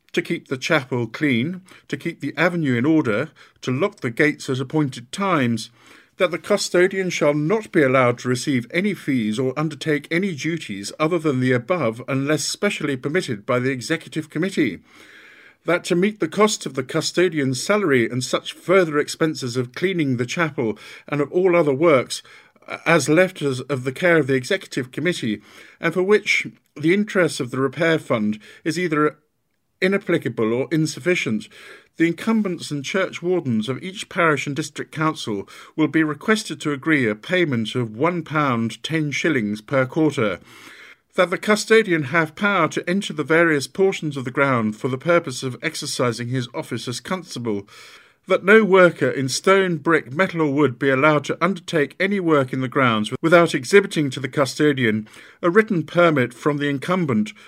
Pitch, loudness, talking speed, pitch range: 155 Hz, -20 LUFS, 175 wpm, 130-175 Hz